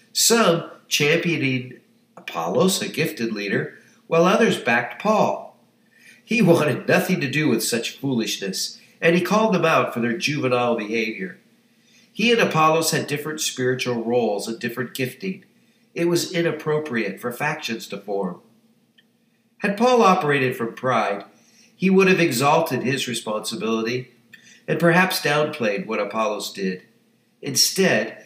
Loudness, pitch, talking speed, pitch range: -21 LUFS, 155 Hz, 130 wpm, 125-195 Hz